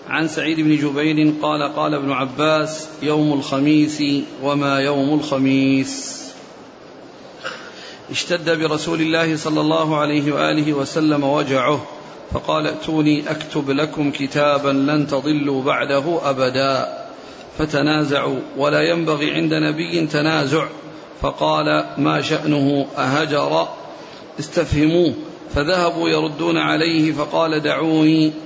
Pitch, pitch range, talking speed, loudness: 150 Hz, 140-155 Hz, 100 wpm, -18 LUFS